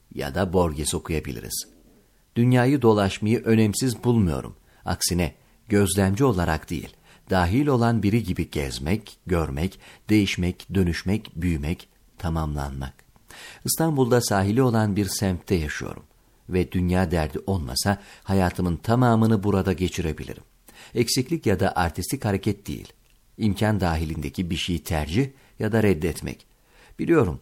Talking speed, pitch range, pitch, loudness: 110 wpm, 85-110 Hz, 95 Hz, -24 LUFS